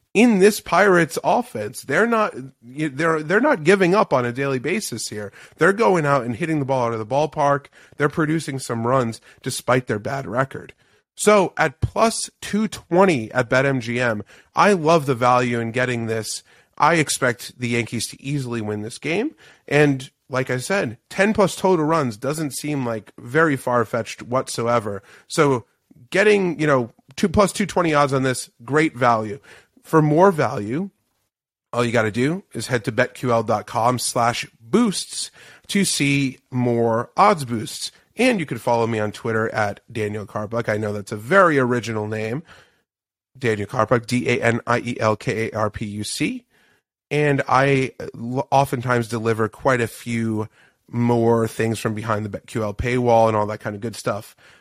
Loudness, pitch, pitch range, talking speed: -20 LUFS, 125 Hz, 115-155 Hz, 170 wpm